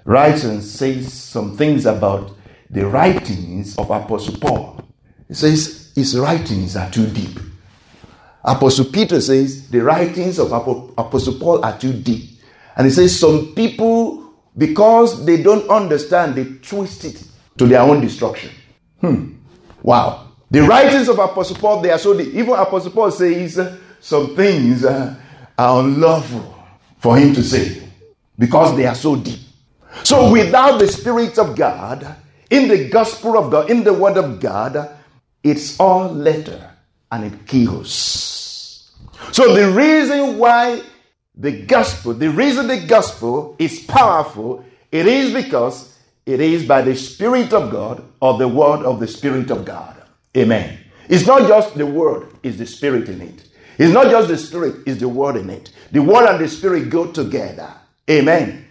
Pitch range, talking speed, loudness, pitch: 125-195 Hz, 155 wpm, -15 LUFS, 145 Hz